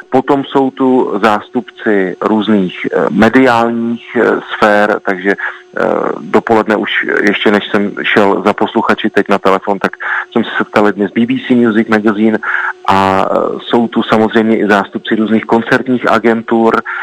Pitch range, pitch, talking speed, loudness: 105-115 Hz, 110 Hz, 125 wpm, -12 LUFS